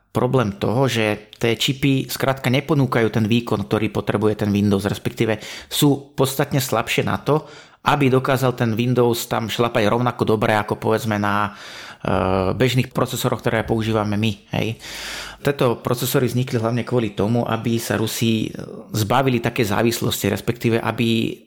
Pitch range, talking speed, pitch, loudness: 110-125 Hz, 140 wpm, 115 Hz, -20 LUFS